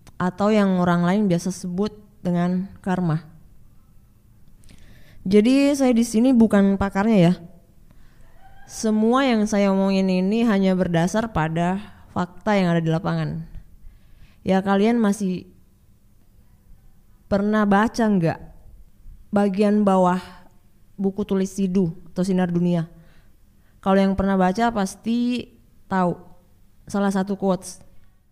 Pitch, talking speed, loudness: 180 Hz, 110 wpm, -21 LUFS